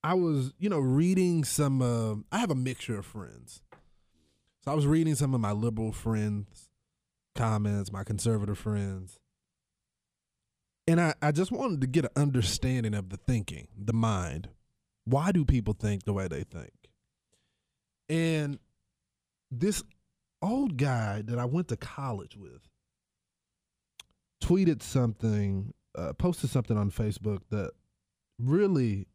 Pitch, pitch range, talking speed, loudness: 120 Hz, 105-150 Hz, 140 wpm, -30 LUFS